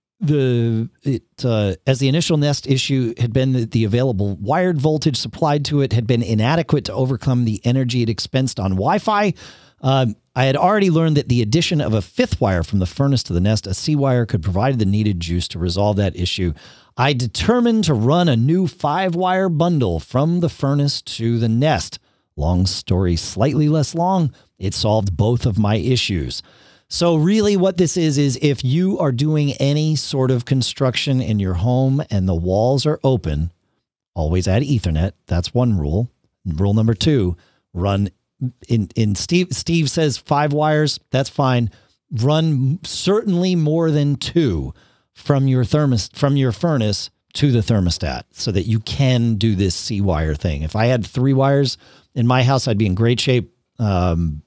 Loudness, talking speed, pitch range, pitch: -18 LUFS, 180 wpm, 105-145 Hz, 125 Hz